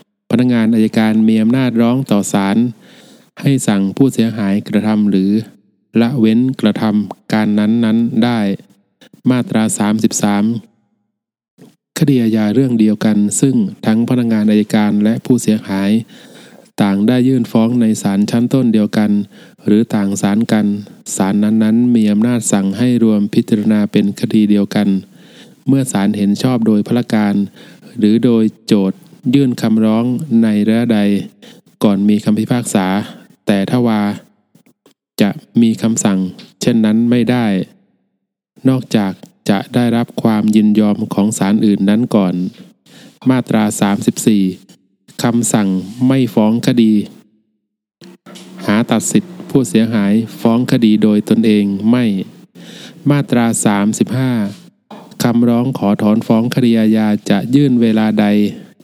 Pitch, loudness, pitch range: 110 Hz, -14 LUFS, 105-120 Hz